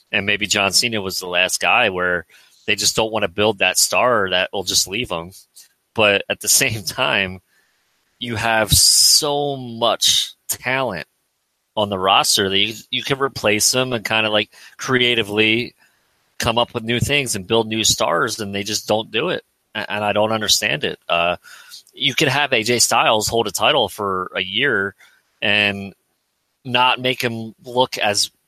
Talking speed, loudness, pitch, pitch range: 175 wpm, -17 LUFS, 110 Hz, 105-120 Hz